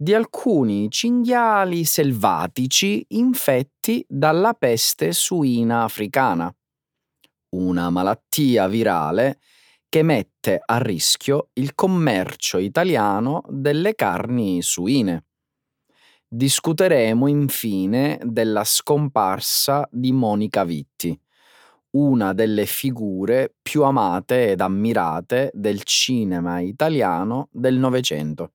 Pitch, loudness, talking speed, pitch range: 130 Hz, -20 LUFS, 85 wpm, 105-150 Hz